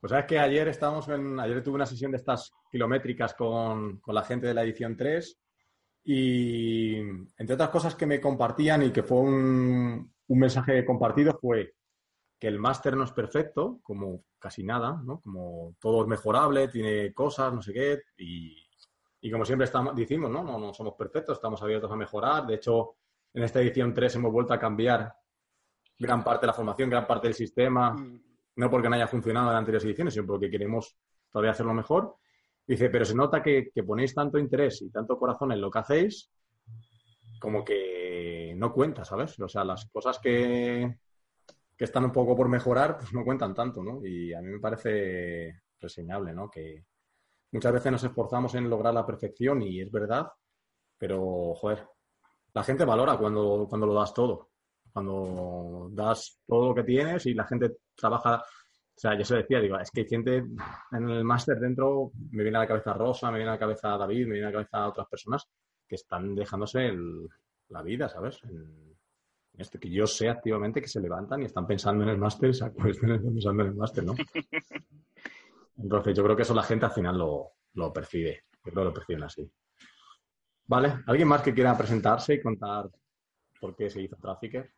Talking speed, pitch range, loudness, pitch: 190 wpm, 105-125 Hz, -28 LUFS, 115 Hz